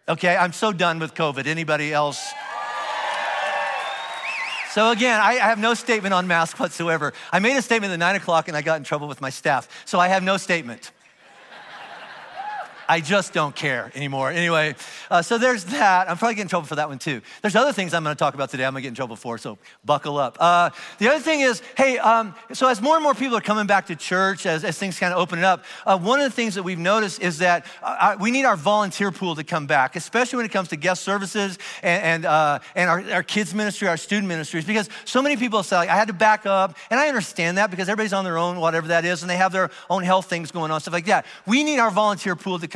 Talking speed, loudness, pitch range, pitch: 250 wpm, -21 LUFS, 165-215 Hz, 185 Hz